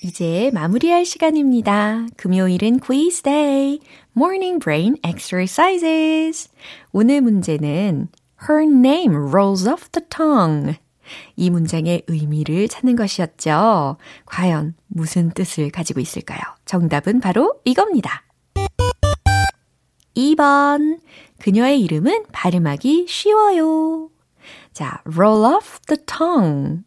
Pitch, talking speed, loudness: 220 Hz, 310 characters per minute, -17 LUFS